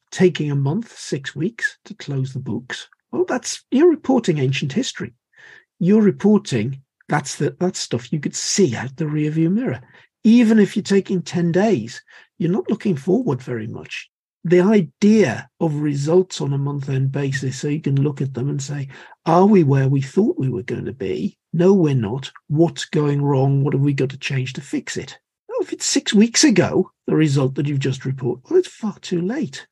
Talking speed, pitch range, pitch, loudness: 200 wpm, 140-200 Hz, 165 Hz, -19 LUFS